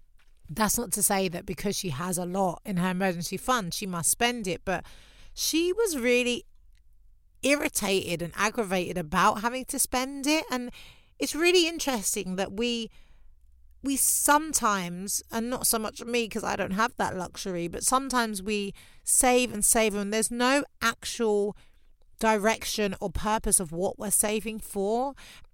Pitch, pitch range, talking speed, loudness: 215 Hz, 190-245 Hz, 155 wpm, -27 LUFS